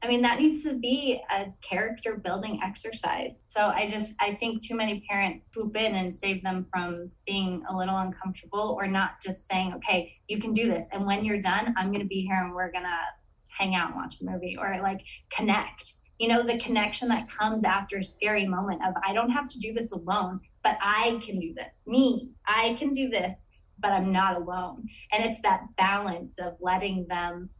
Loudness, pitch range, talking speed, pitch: -28 LUFS, 185-225 Hz, 215 wpm, 200 Hz